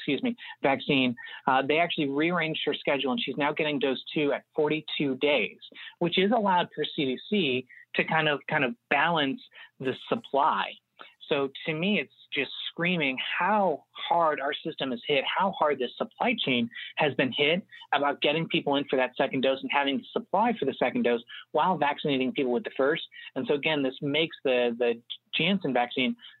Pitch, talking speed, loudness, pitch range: 145 Hz, 185 wpm, -27 LUFS, 130-165 Hz